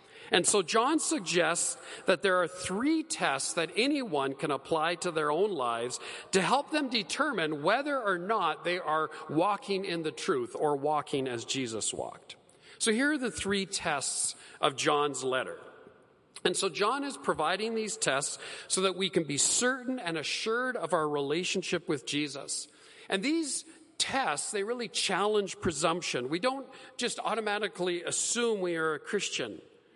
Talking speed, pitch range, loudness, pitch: 160 wpm, 160-255 Hz, -30 LUFS, 195 Hz